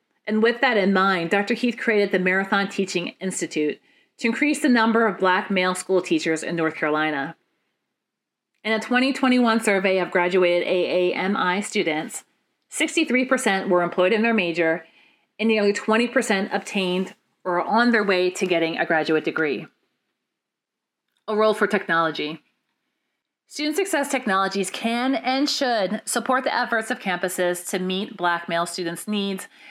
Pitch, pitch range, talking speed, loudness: 200 Hz, 180-235 Hz, 145 wpm, -22 LUFS